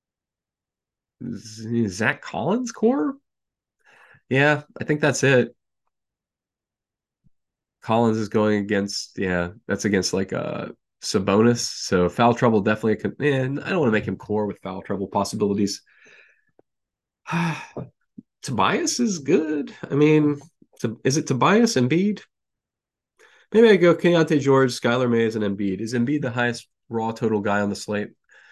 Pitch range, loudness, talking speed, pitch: 105-150 Hz, -22 LUFS, 135 wpm, 120 Hz